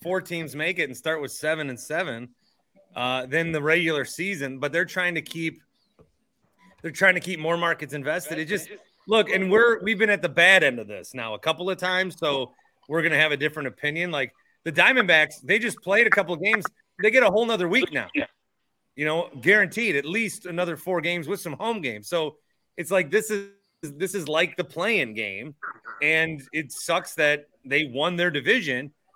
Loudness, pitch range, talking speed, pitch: -23 LUFS, 155-190 Hz, 205 wpm, 170 Hz